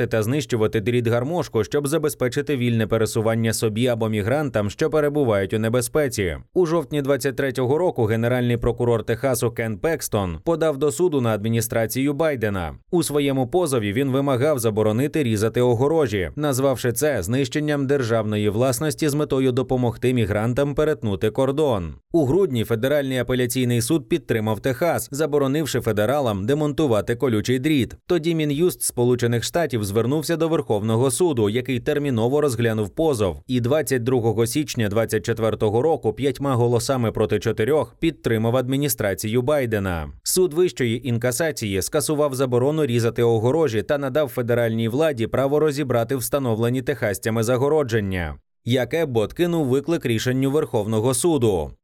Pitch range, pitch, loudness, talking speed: 115-150 Hz, 125 Hz, -21 LUFS, 125 wpm